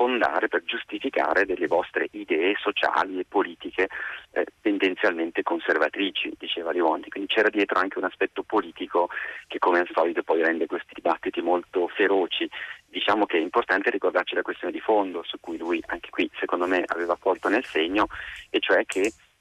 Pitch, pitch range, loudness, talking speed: 350 Hz, 330-400 Hz, -25 LUFS, 165 wpm